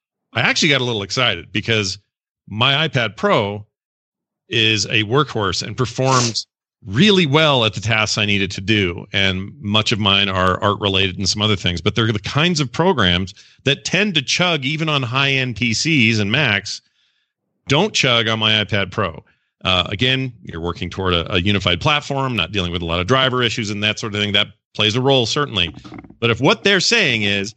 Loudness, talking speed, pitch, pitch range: -17 LUFS, 200 wpm, 110 Hz, 100-135 Hz